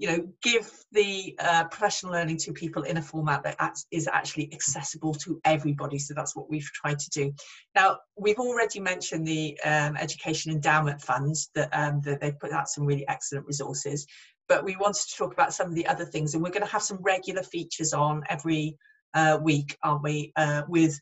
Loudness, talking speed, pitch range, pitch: -27 LUFS, 205 wpm, 150-185 Hz, 160 Hz